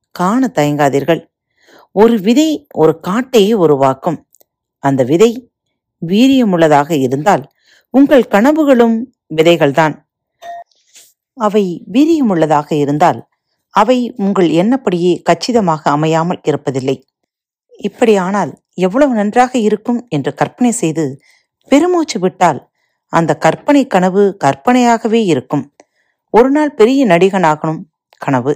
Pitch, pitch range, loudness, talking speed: 190 Hz, 160-240 Hz, -12 LUFS, 85 wpm